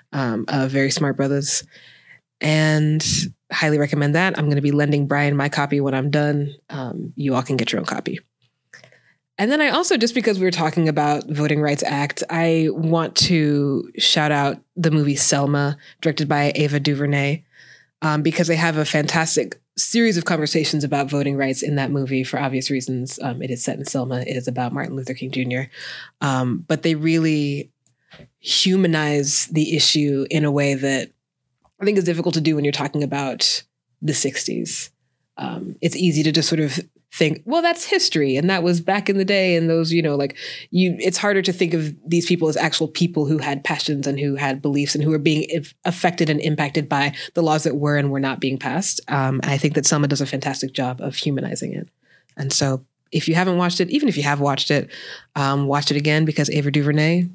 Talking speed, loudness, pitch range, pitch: 210 wpm, -20 LUFS, 140-165 Hz, 150 Hz